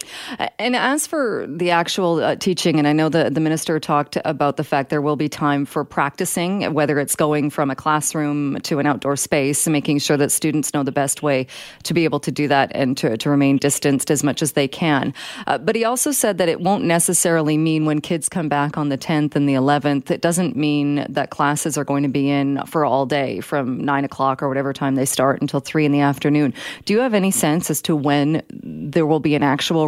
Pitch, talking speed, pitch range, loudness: 150 Hz, 235 wpm, 140-165 Hz, -19 LUFS